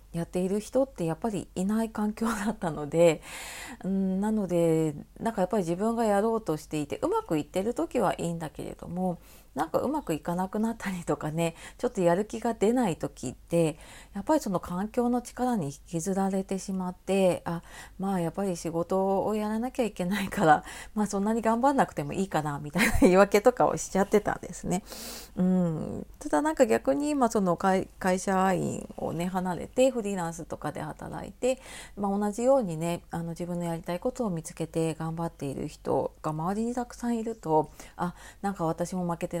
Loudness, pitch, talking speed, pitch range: -29 LUFS, 190 Hz, 395 characters per minute, 170-225 Hz